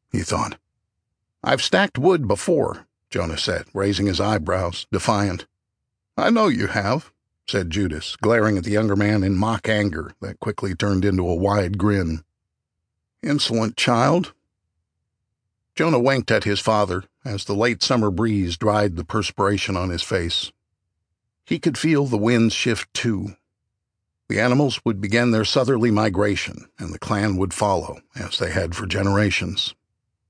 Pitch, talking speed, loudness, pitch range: 100 Hz, 150 wpm, -21 LUFS, 95-110 Hz